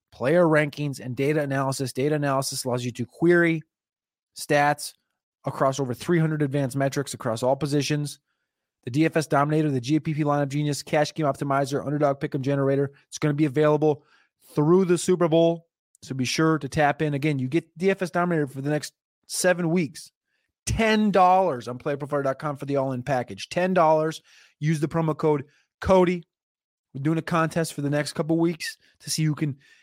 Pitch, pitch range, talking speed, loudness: 150 Hz, 140-165 Hz, 170 wpm, -24 LUFS